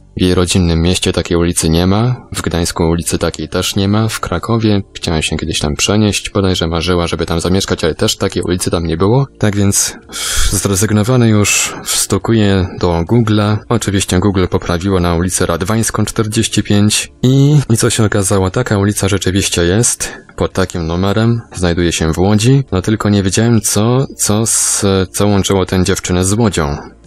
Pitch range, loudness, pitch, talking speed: 90-105 Hz, -13 LUFS, 100 Hz, 170 wpm